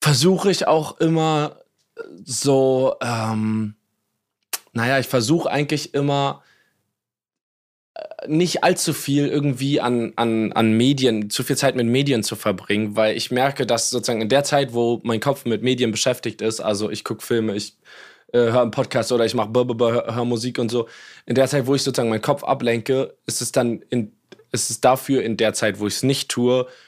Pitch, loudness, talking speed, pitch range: 125 Hz, -20 LUFS, 185 wpm, 110-140 Hz